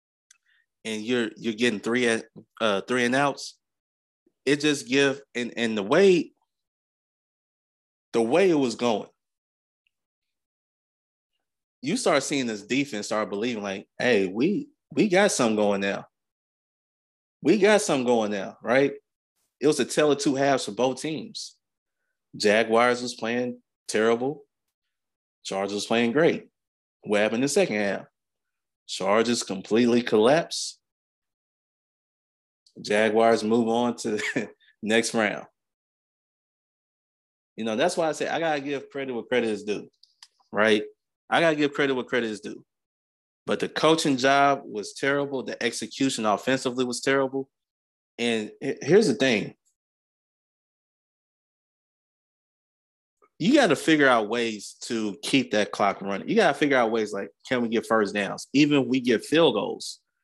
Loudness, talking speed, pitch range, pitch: -24 LUFS, 145 wpm, 110-140 Hz, 120 Hz